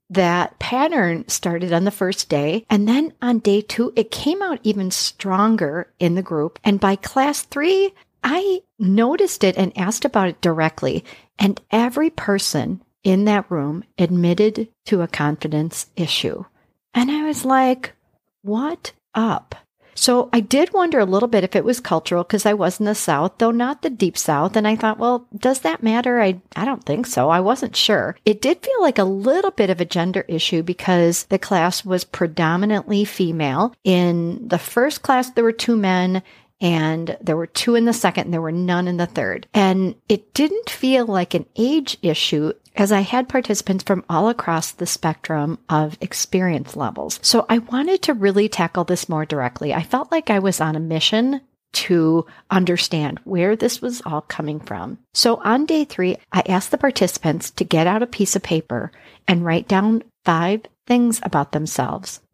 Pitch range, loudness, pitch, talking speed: 175-235 Hz, -19 LUFS, 195 Hz, 185 wpm